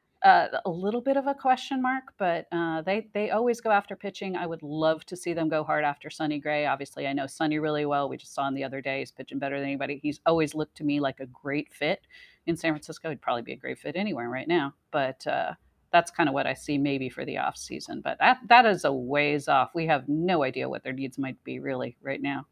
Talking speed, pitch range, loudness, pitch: 260 wpm, 140-180 Hz, -27 LUFS, 155 Hz